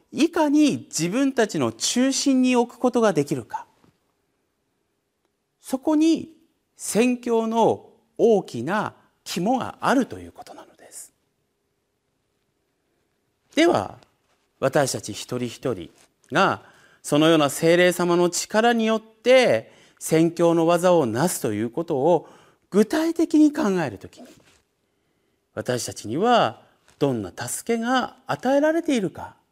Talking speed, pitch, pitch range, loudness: 220 characters per minute, 230 Hz, 170-275 Hz, -22 LUFS